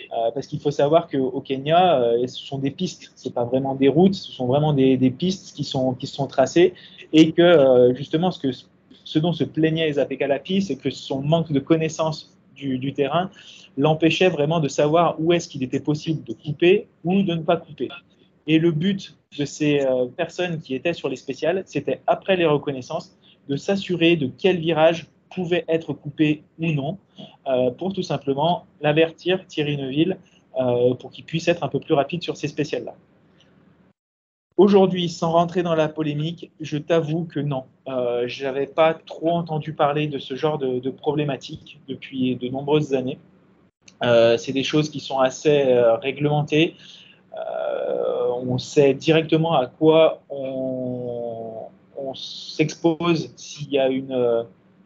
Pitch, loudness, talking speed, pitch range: 150 Hz, -21 LUFS, 175 wpm, 135-170 Hz